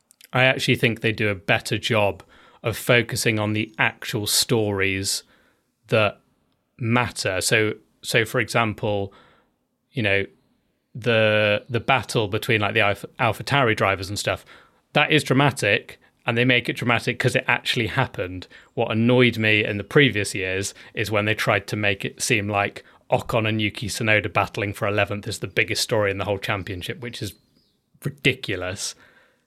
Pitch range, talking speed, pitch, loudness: 100-125 Hz, 165 wpm, 110 Hz, -22 LUFS